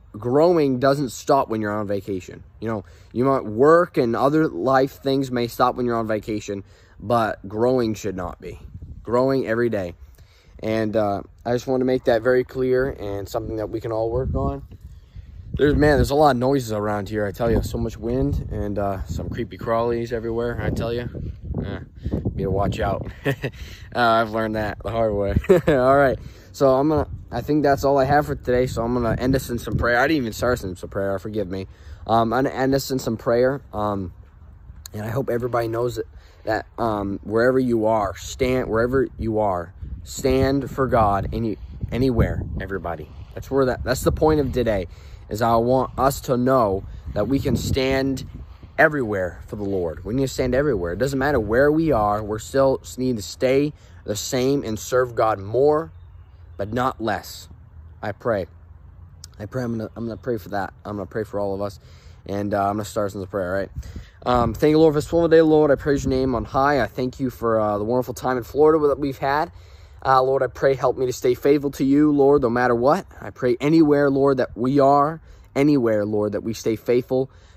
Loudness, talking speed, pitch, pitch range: -21 LUFS, 215 wpm, 115 Hz, 100-130 Hz